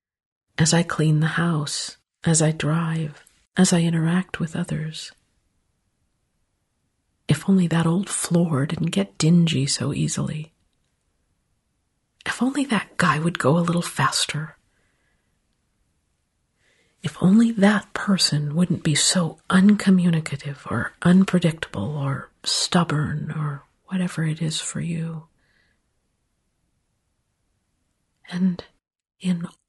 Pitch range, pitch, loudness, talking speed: 145-180 Hz, 165 Hz, -22 LUFS, 105 wpm